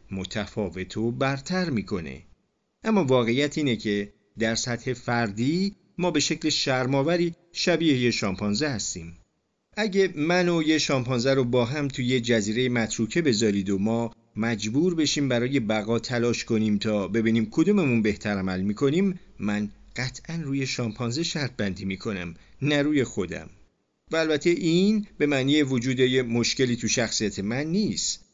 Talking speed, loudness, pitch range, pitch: 140 wpm, -25 LUFS, 110-150 Hz, 125 Hz